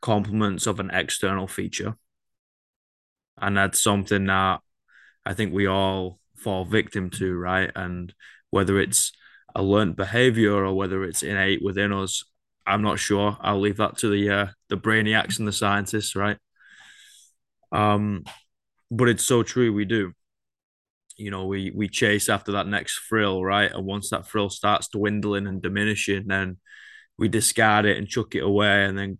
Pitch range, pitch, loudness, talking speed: 95-105 Hz, 100 Hz, -23 LUFS, 160 wpm